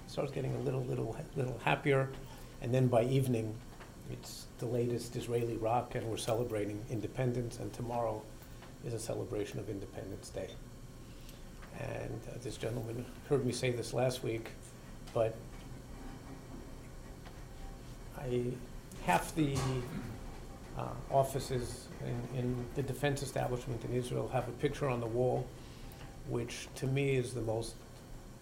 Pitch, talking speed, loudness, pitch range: 125 Hz, 135 wpm, -37 LUFS, 115-130 Hz